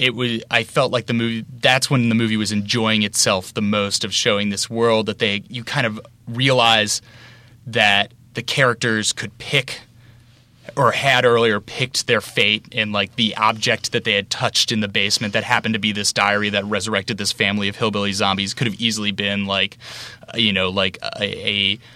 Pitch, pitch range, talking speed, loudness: 115 Hz, 105-120 Hz, 195 wpm, -18 LUFS